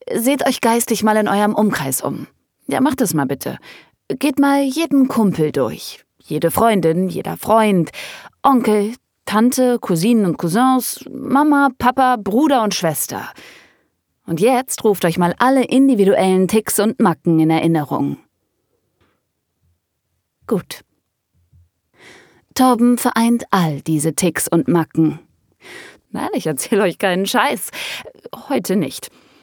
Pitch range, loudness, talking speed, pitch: 165-250 Hz, -16 LUFS, 120 wpm, 210 Hz